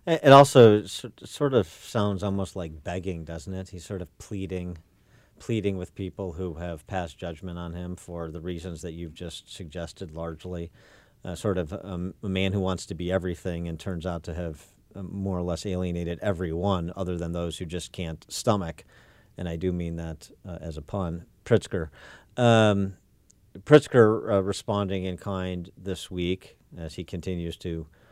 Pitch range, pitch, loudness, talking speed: 85-100 Hz, 90 Hz, -27 LUFS, 175 wpm